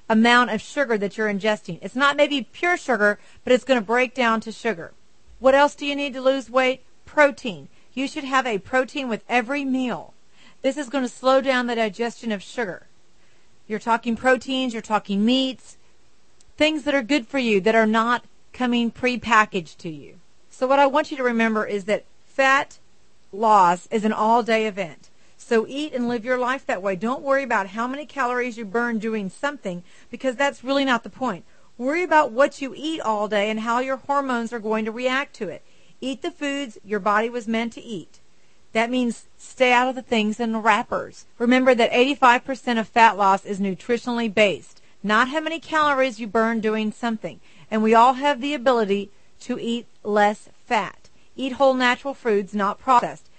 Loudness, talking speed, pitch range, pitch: -22 LUFS, 195 wpm, 220-265 Hz, 240 Hz